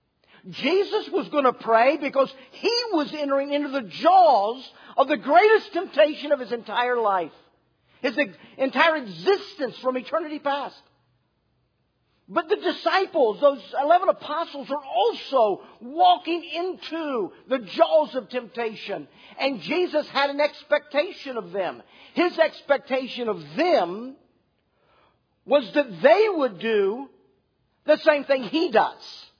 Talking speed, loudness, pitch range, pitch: 125 wpm, -23 LUFS, 240-320 Hz, 285 Hz